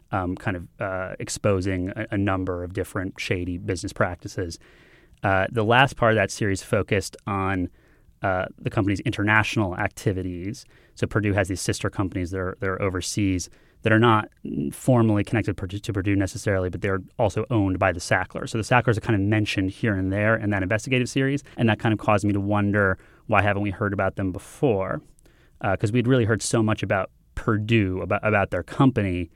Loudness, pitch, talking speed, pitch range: -24 LUFS, 100 Hz, 195 wpm, 95-110 Hz